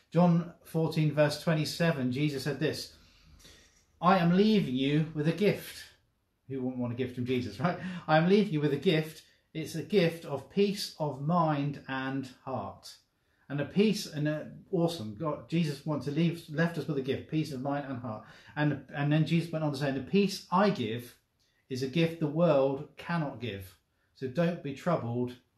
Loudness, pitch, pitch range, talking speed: -30 LUFS, 150 Hz, 130-165 Hz, 195 wpm